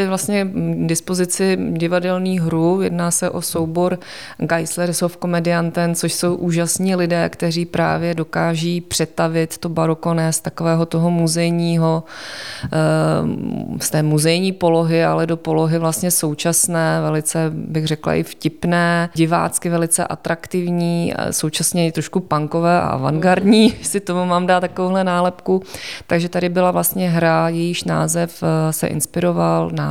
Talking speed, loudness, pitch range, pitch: 130 wpm, -18 LUFS, 160-175 Hz, 170 Hz